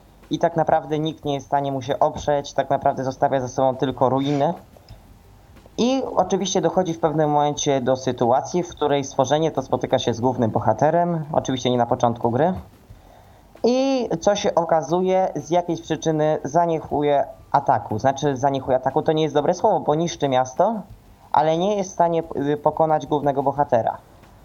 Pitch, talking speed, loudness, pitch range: 145 Hz, 165 wpm, -21 LUFS, 130-165 Hz